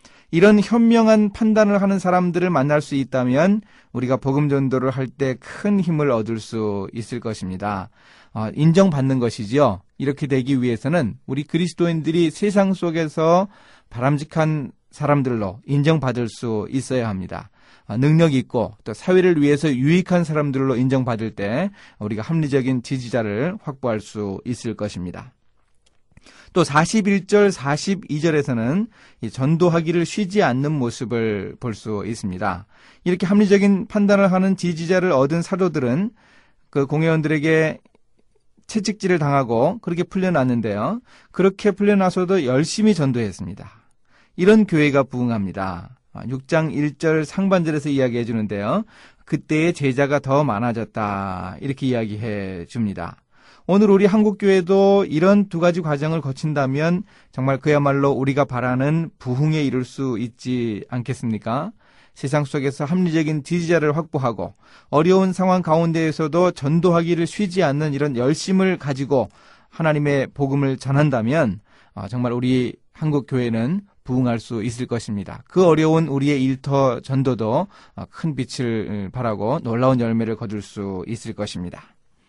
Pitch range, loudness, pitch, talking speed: 120-175 Hz, -20 LUFS, 140 Hz, 310 characters per minute